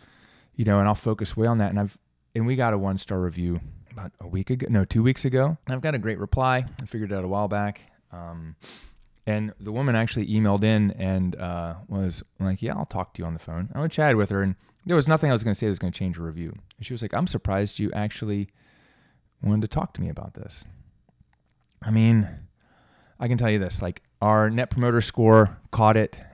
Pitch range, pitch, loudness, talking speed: 95-115 Hz, 105 Hz, -24 LUFS, 245 wpm